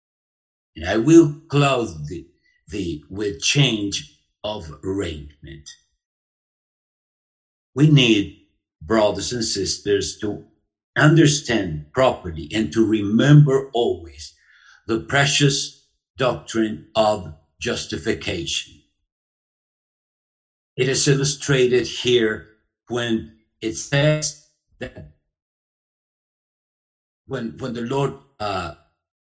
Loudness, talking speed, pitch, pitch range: -20 LUFS, 80 wpm, 110 Hz, 85-135 Hz